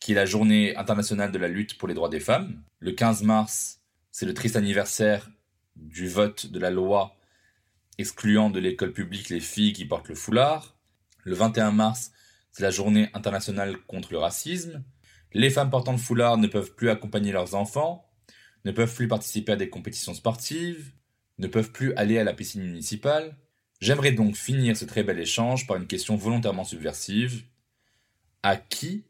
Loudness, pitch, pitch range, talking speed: -26 LUFS, 110 Hz, 100-120 Hz, 175 wpm